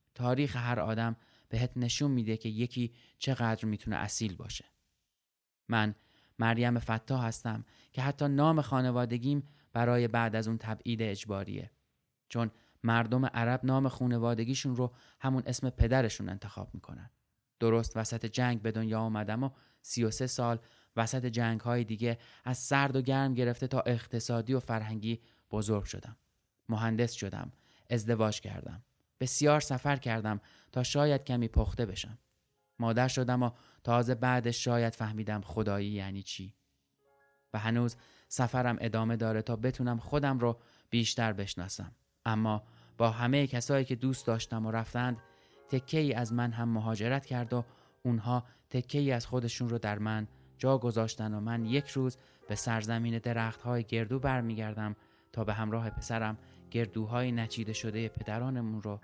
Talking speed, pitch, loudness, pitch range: 145 wpm, 115 Hz, -33 LUFS, 110-125 Hz